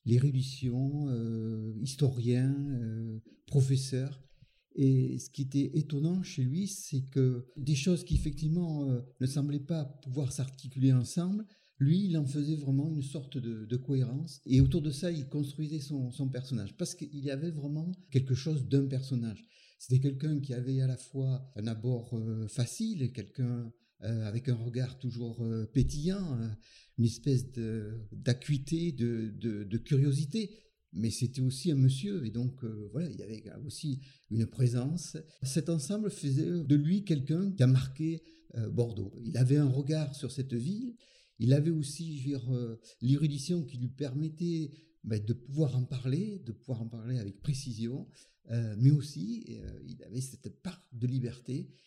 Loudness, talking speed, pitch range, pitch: -33 LUFS, 165 wpm, 125-155 Hz, 135 Hz